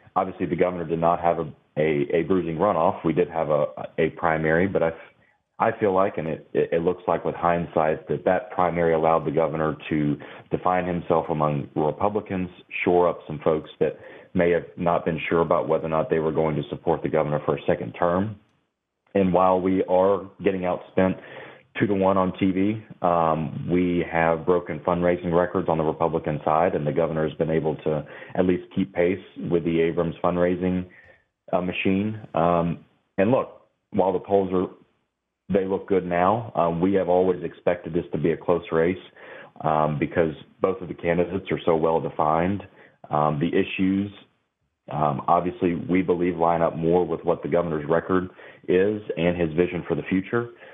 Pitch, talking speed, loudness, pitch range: 85 Hz, 185 wpm, -24 LUFS, 80-95 Hz